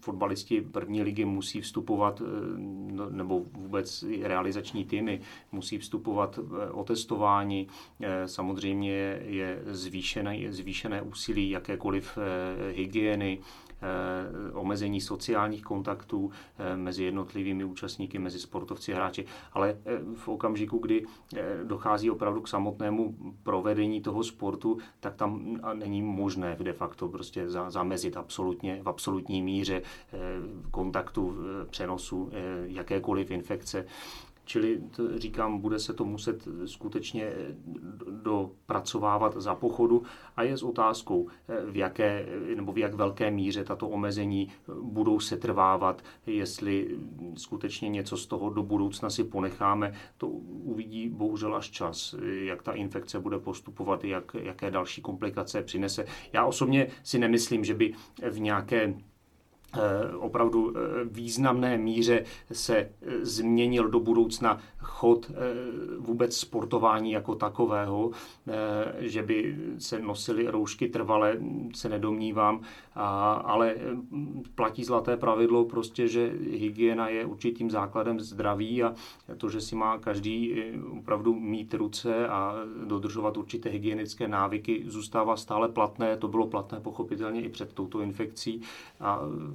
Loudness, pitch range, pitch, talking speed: -31 LUFS, 100-115 Hz, 105 Hz, 115 wpm